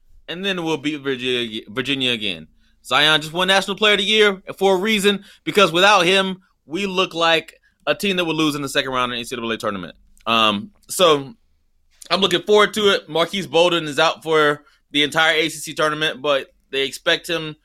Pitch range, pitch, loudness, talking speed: 125-190 Hz, 155 Hz, -18 LUFS, 195 wpm